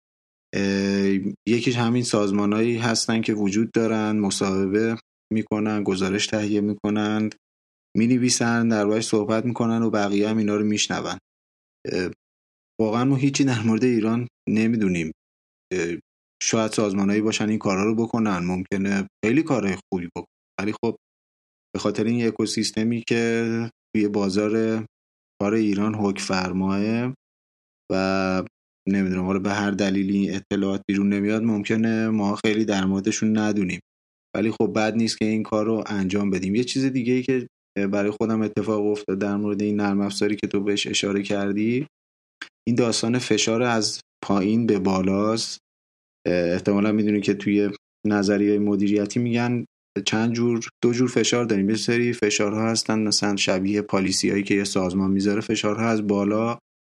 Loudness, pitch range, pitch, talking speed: -23 LUFS, 100-110 Hz, 105 Hz, 145 wpm